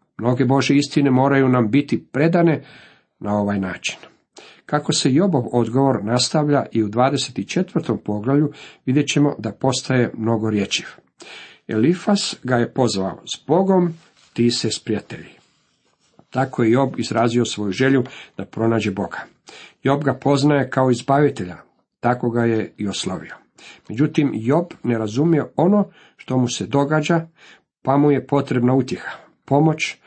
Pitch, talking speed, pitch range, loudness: 130 Hz, 135 wpm, 115-145 Hz, -19 LUFS